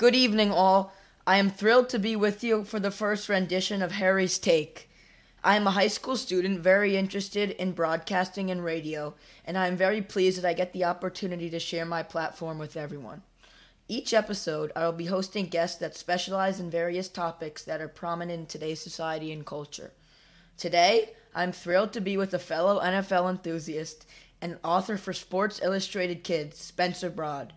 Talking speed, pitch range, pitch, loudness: 185 wpm, 165-195 Hz, 180 Hz, -28 LUFS